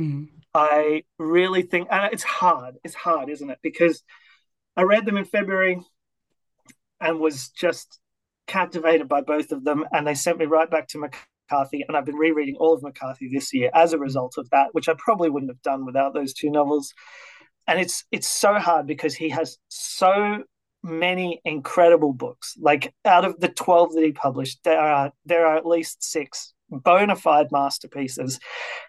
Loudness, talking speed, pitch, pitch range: -22 LUFS, 180 wpm, 160 Hz, 145-175 Hz